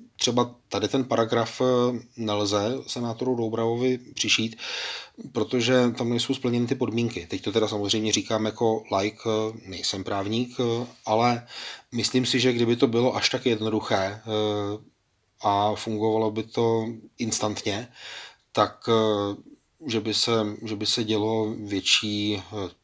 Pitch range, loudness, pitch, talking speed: 105-120 Hz, -25 LUFS, 110 Hz, 125 wpm